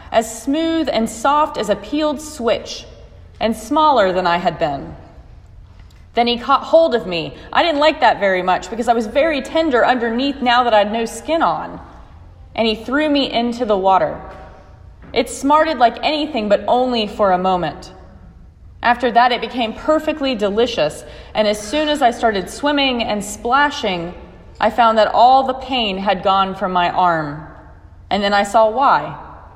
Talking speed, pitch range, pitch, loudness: 175 wpm, 190-270 Hz, 230 Hz, -16 LUFS